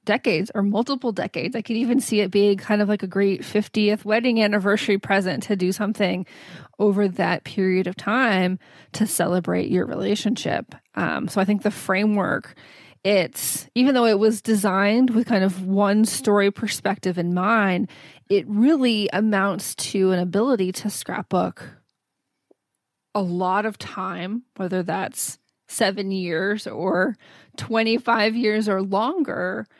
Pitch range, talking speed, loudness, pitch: 190-220 Hz, 145 wpm, -22 LUFS, 205 Hz